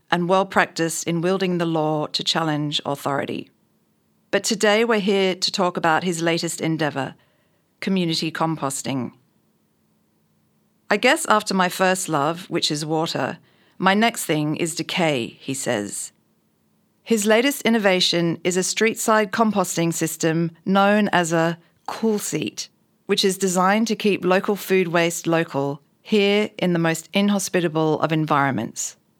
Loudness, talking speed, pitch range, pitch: -21 LUFS, 140 wpm, 160-200 Hz, 175 Hz